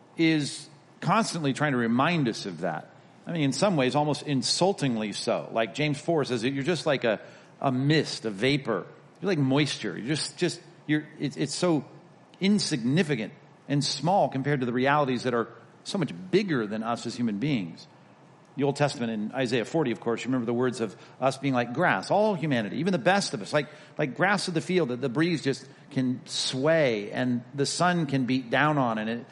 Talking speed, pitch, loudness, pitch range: 205 wpm, 145 Hz, -27 LUFS, 125-160 Hz